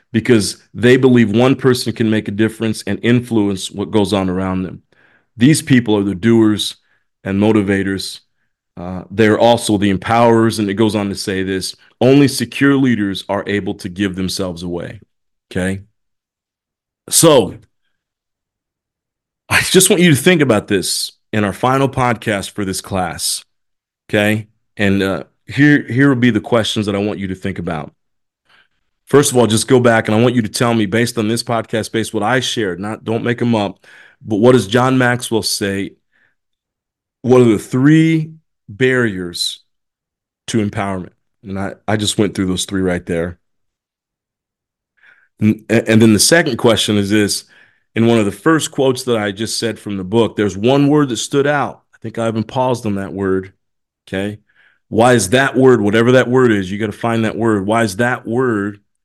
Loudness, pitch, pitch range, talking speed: -15 LUFS, 110 Hz, 100-120 Hz, 185 wpm